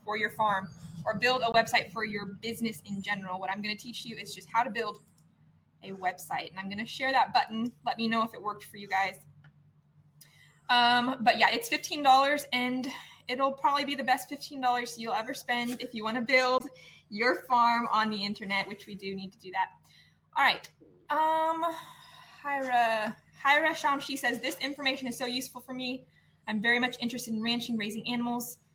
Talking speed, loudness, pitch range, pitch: 200 wpm, -30 LUFS, 205-255 Hz, 235 Hz